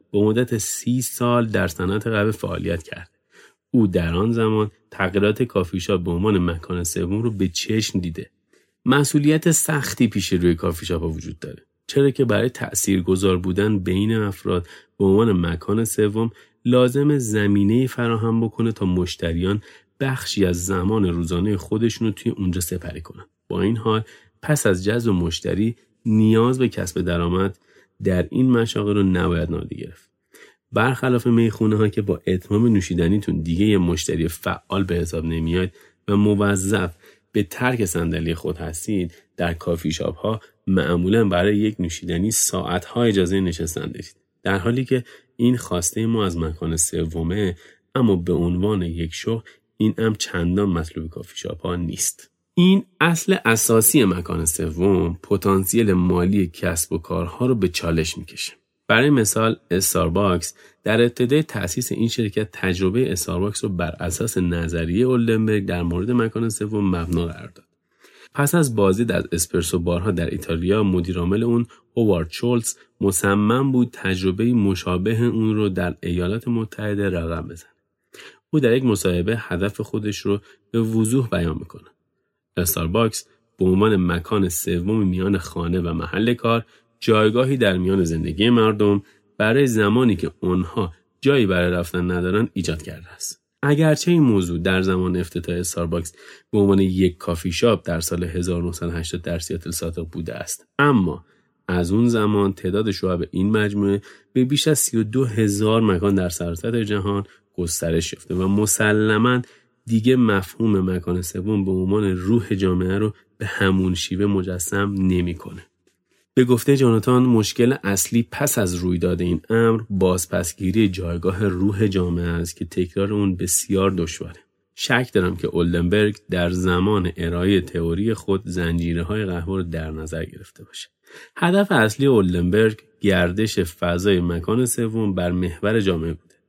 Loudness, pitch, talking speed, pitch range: -21 LUFS, 100 Hz, 145 wpm, 90-110 Hz